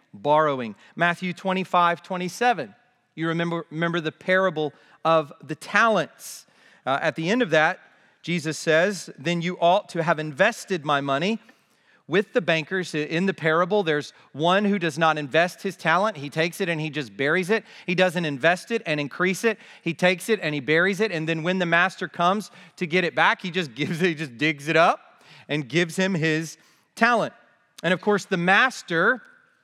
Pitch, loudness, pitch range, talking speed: 175 Hz, -23 LUFS, 155-190 Hz, 185 wpm